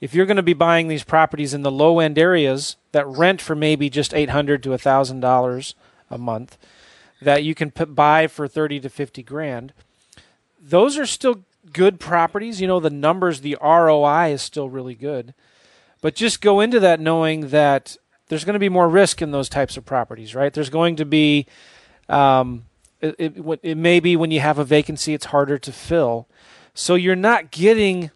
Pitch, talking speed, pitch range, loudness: 155 Hz, 195 wpm, 140-170 Hz, -18 LUFS